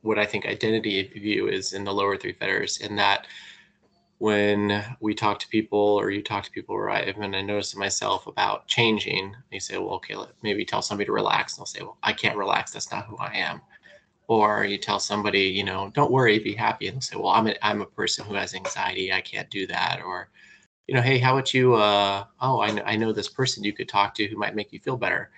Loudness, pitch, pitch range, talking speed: -25 LUFS, 105 Hz, 100-110 Hz, 245 wpm